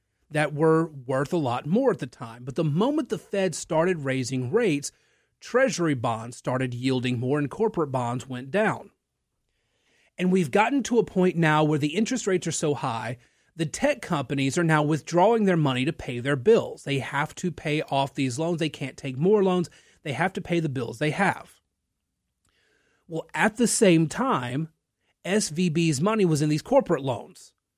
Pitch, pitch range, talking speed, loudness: 160 Hz, 135-185 Hz, 185 wpm, -25 LUFS